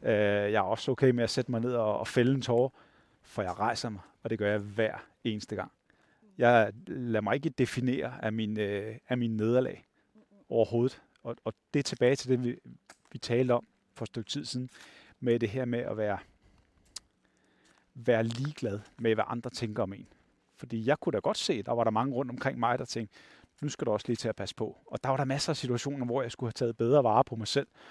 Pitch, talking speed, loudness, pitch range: 120 Hz, 230 wpm, -31 LUFS, 110-130 Hz